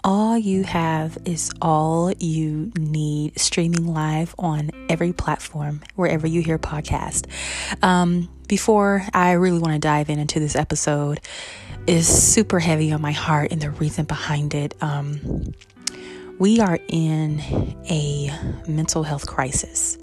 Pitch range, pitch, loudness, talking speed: 150-170 Hz, 155 Hz, -21 LUFS, 140 wpm